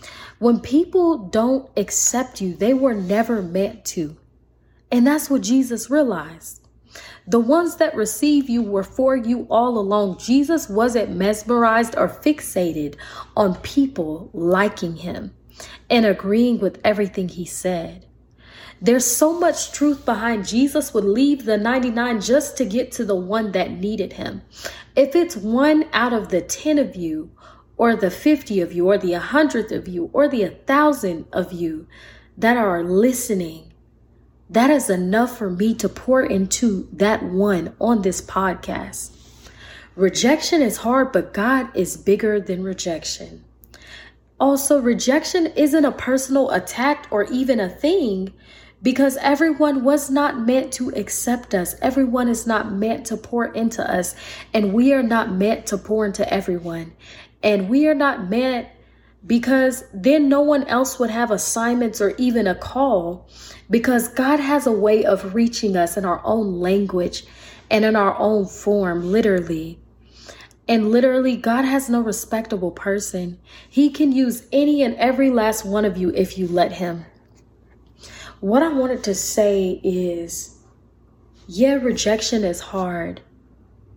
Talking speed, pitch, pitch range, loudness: 150 wpm, 220 Hz, 190-260 Hz, -19 LUFS